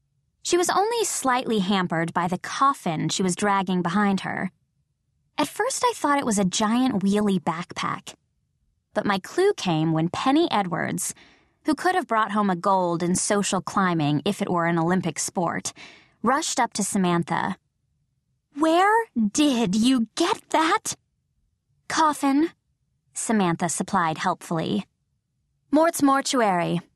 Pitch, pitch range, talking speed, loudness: 205 Hz, 180-280 Hz, 135 wpm, -23 LUFS